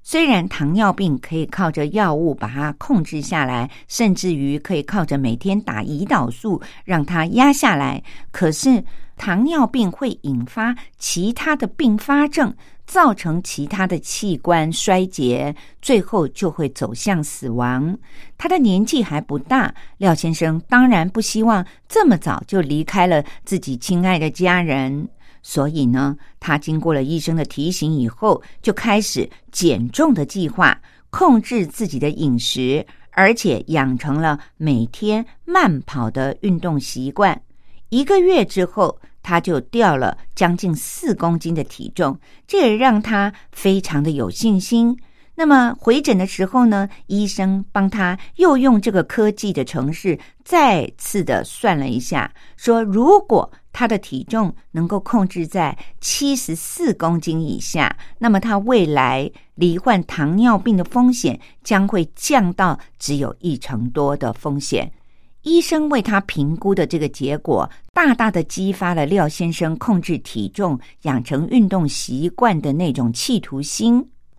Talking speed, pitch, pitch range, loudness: 220 characters per minute, 180 Hz, 150-225 Hz, -18 LUFS